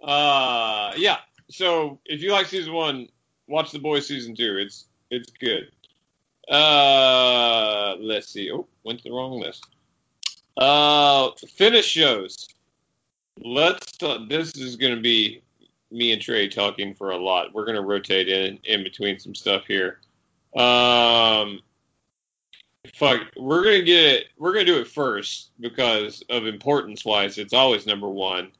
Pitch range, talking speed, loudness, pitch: 105-145 Hz, 145 wpm, -20 LUFS, 120 Hz